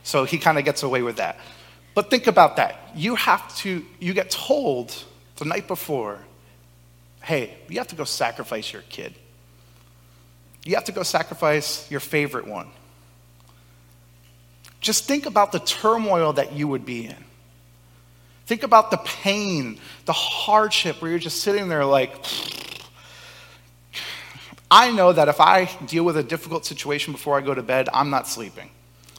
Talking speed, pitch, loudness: 160 wpm, 140 Hz, -21 LUFS